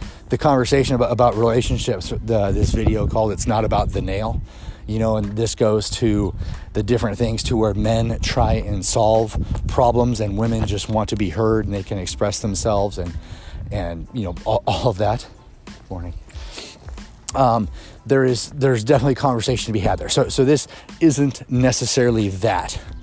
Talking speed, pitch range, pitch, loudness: 175 wpm, 100-120 Hz, 110 Hz, -20 LUFS